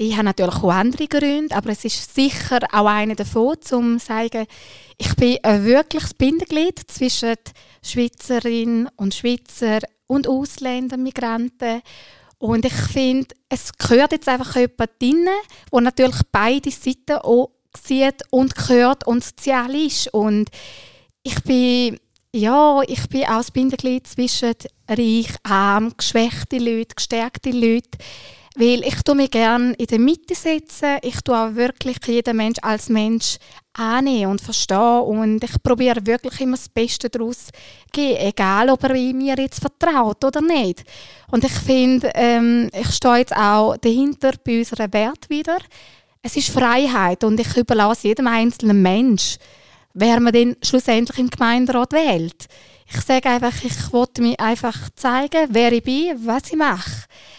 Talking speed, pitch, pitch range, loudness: 150 wpm, 245 Hz, 230-265 Hz, -18 LUFS